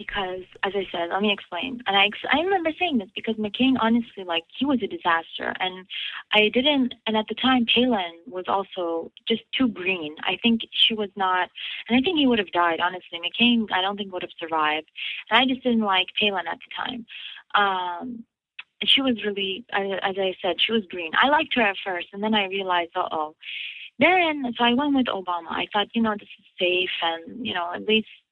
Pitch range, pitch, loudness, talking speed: 180-235 Hz, 205 Hz, -23 LUFS, 220 wpm